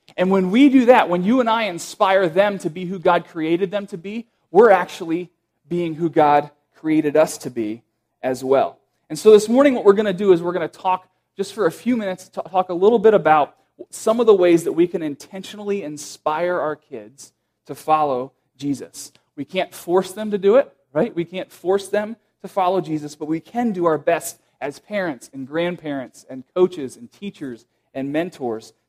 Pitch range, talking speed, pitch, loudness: 150-200 Hz, 210 wpm, 175 Hz, -19 LUFS